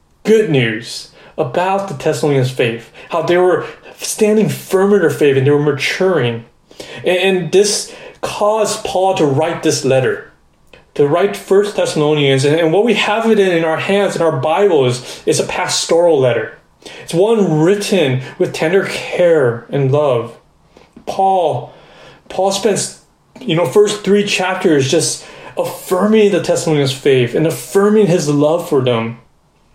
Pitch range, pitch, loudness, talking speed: 150-205 Hz, 175 Hz, -14 LUFS, 140 wpm